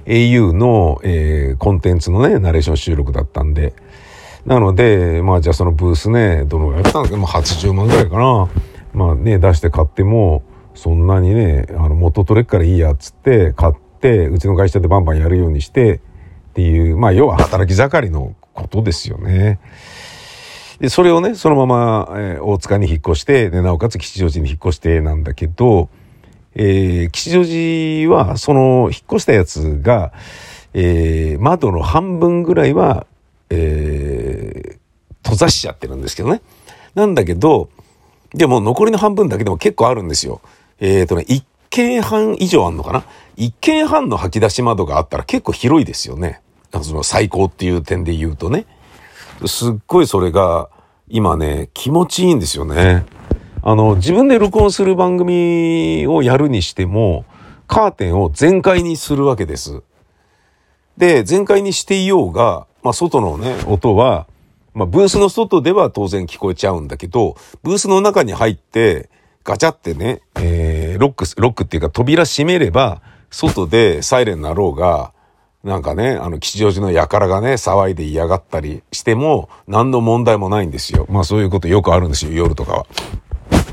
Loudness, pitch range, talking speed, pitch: -14 LUFS, 85-125 Hz, 340 characters per minute, 100 Hz